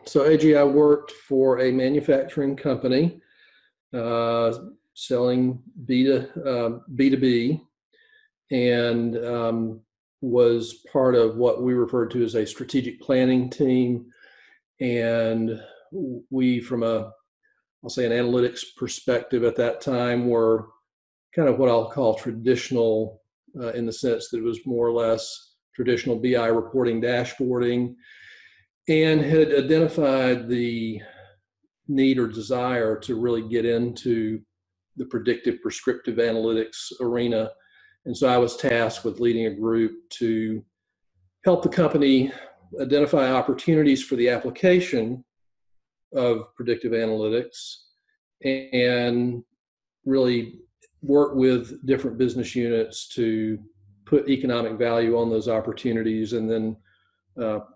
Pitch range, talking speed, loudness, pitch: 115-135 Hz, 120 wpm, -23 LUFS, 120 Hz